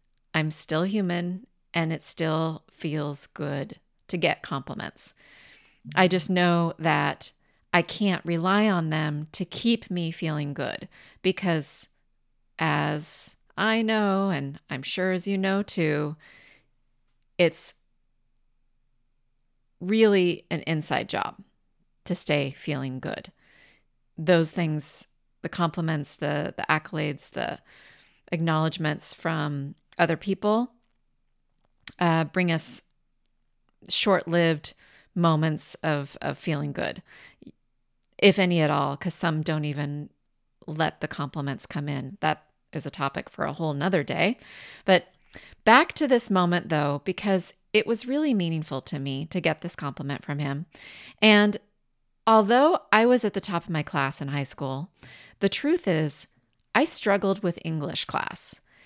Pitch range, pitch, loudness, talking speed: 145-185 Hz, 160 Hz, -26 LUFS, 130 wpm